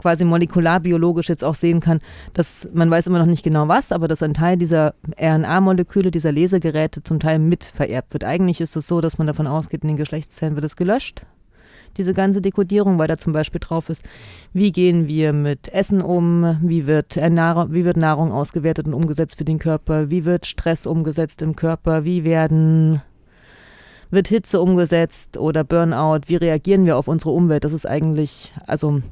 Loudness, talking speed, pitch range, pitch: -18 LUFS, 185 wpm, 155-175 Hz, 165 Hz